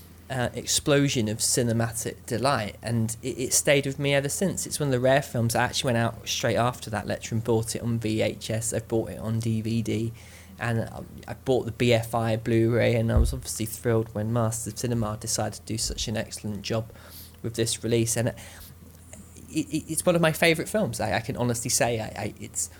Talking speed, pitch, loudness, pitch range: 210 wpm, 115 Hz, -26 LUFS, 105-120 Hz